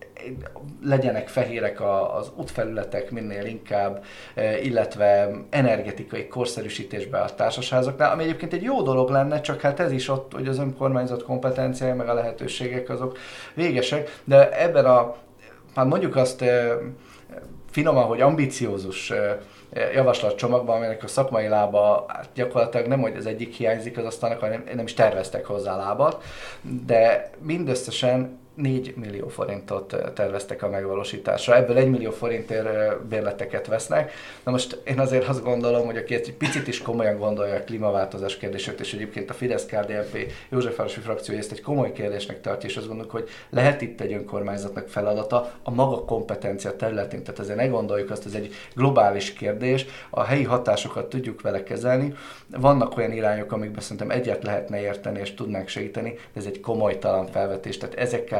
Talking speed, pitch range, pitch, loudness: 150 wpm, 105-130 Hz, 120 Hz, -24 LUFS